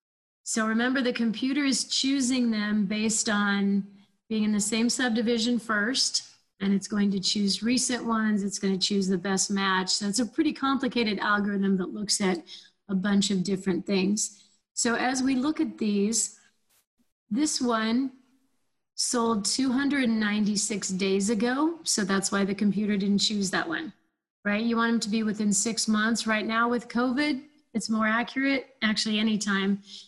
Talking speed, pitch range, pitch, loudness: 165 wpm, 200-240 Hz, 215 Hz, -26 LUFS